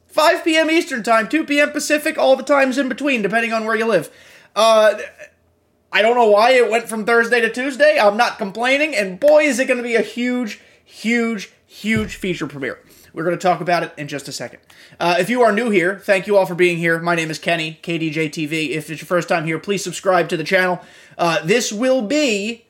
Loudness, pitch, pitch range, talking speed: -17 LUFS, 220 Hz, 175-255 Hz, 225 wpm